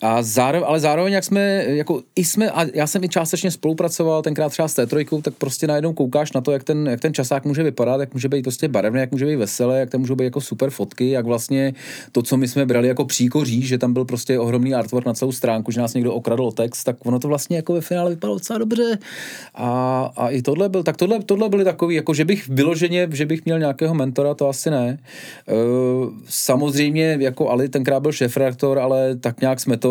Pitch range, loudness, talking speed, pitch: 125-160 Hz, -20 LUFS, 230 wpm, 140 Hz